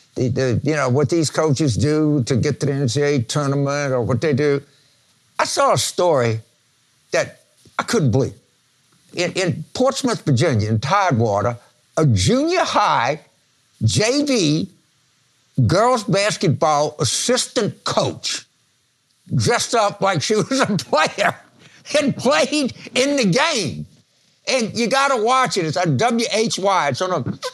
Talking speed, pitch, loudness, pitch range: 140 wpm, 155 Hz, -19 LUFS, 140-230 Hz